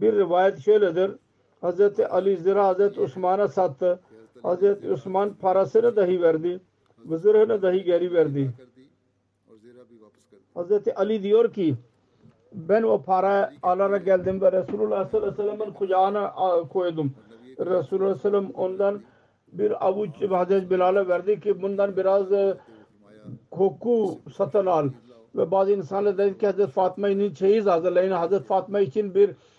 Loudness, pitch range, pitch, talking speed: -23 LUFS, 175-205 Hz, 190 Hz, 130 wpm